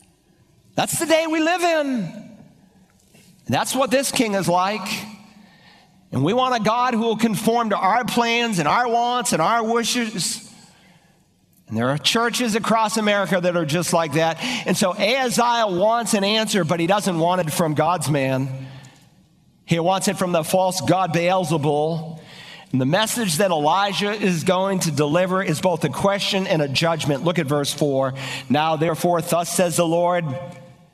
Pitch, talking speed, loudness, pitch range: 185 Hz, 175 wpm, -20 LUFS, 165-220 Hz